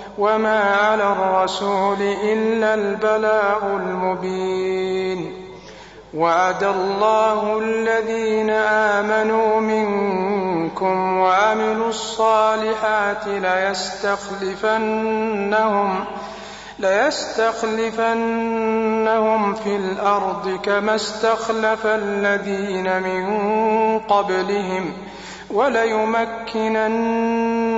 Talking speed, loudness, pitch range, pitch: 50 wpm, -19 LUFS, 195-220 Hz, 210 Hz